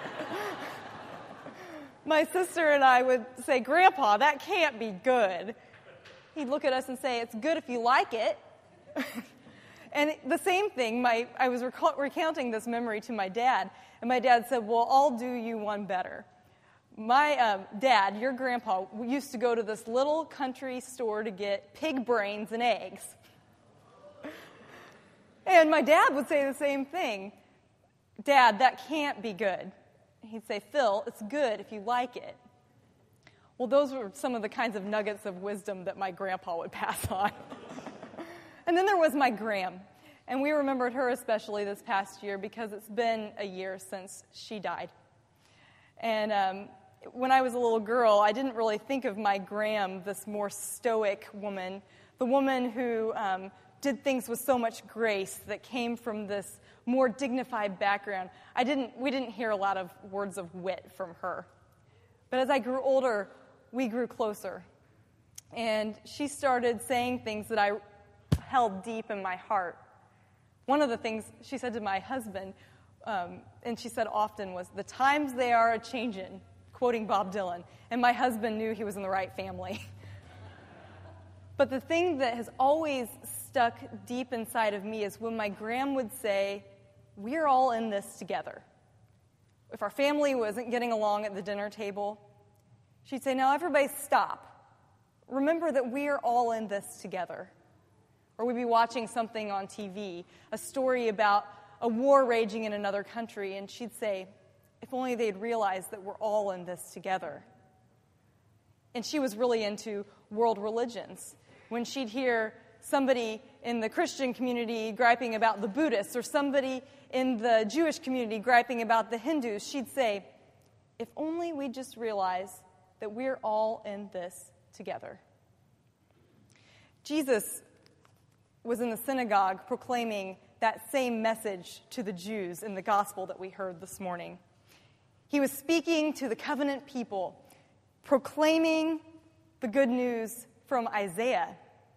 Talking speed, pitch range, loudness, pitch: 160 wpm, 200-260 Hz, -30 LUFS, 230 Hz